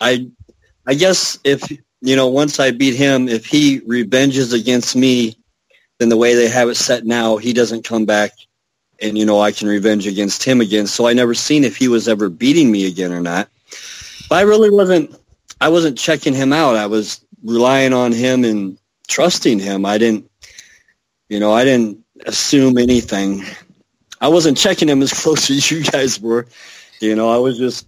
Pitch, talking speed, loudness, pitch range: 120 Hz, 190 wpm, -14 LUFS, 110-135 Hz